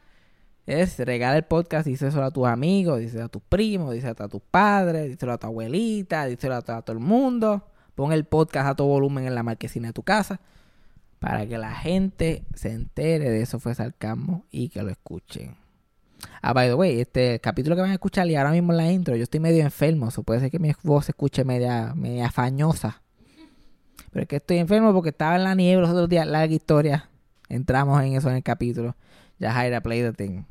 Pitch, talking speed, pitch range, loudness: 140 Hz, 215 wpm, 120-170 Hz, -23 LUFS